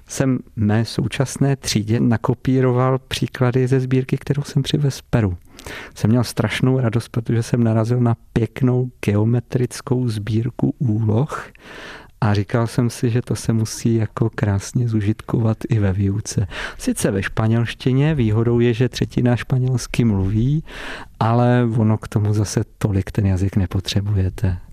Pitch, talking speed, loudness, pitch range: 115 Hz, 135 wpm, -20 LUFS, 110-130 Hz